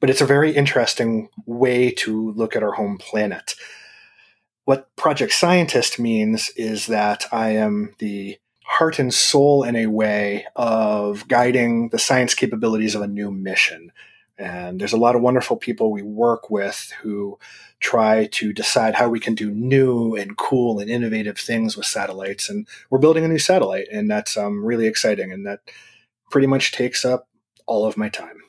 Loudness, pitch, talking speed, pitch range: -19 LUFS, 115 Hz, 175 wpm, 105-125 Hz